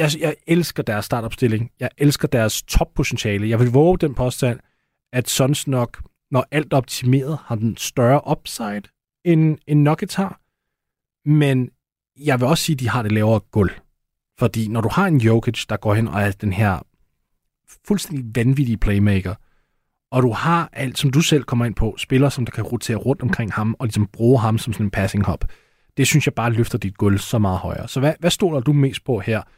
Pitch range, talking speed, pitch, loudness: 110-145 Hz, 205 wpm, 125 Hz, -20 LUFS